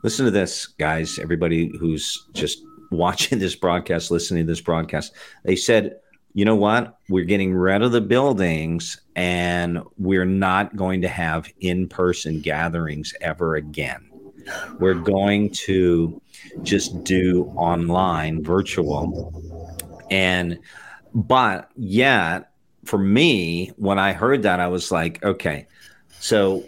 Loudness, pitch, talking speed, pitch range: -21 LUFS, 90 Hz, 130 wpm, 85-95 Hz